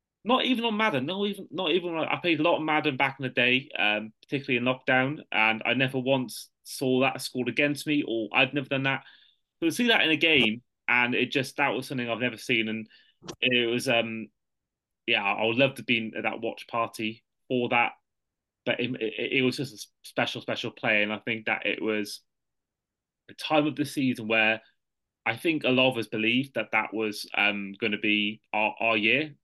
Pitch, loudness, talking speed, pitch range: 125 Hz, -26 LUFS, 215 wpm, 110-140 Hz